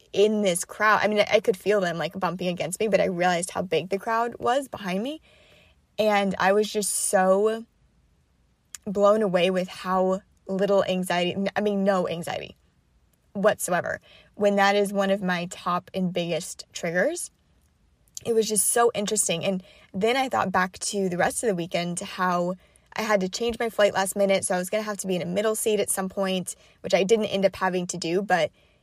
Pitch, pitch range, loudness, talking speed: 195 Hz, 185-210 Hz, -24 LUFS, 205 wpm